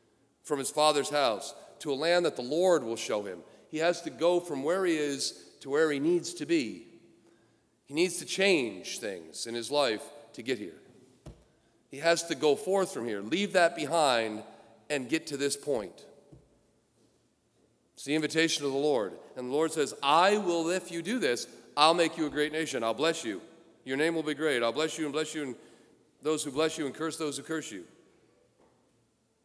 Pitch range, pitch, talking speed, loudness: 145-170 Hz, 155 Hz, 205 wpm, -29 LUFS